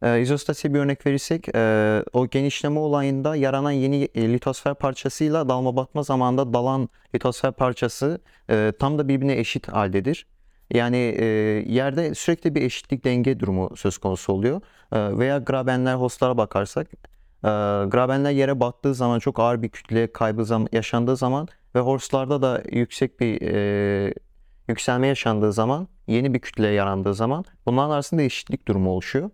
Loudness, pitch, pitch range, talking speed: -23 LUFS, 125 Hz, 110-140 Hz, 135 wpm